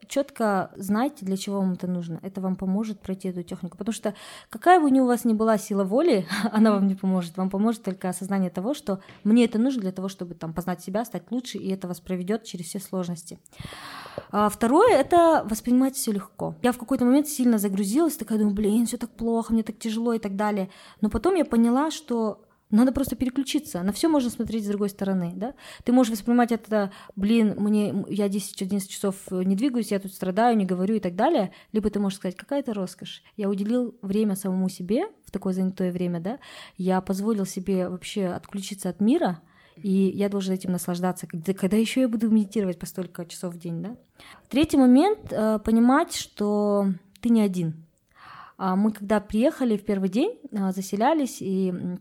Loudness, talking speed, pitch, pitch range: -25 LUFS, 190 wpm, 205 Hz, 190-235 Hz